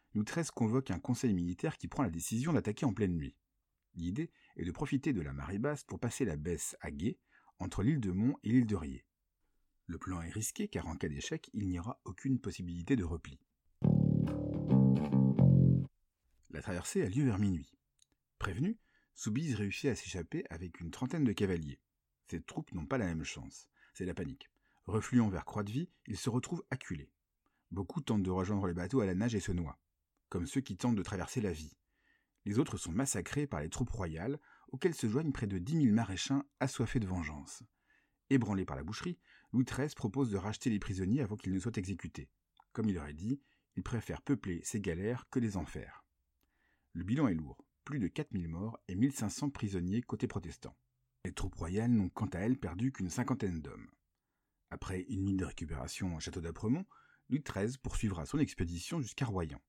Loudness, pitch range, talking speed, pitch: -36 LUFS, 90-130 Hz, 190 wpm, 105 Hz